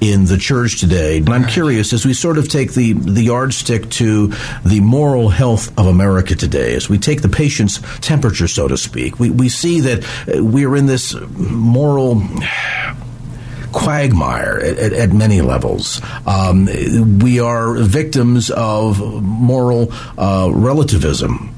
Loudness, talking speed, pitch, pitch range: -14 LUFS, 150 wpm, 115 Hz, 100-130 Hz